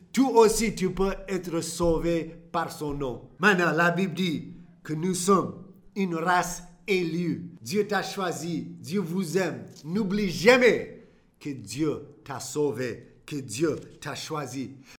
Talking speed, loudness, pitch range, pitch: 140 wpm, -26 LUFS, 150-190 Hz, 170 Hz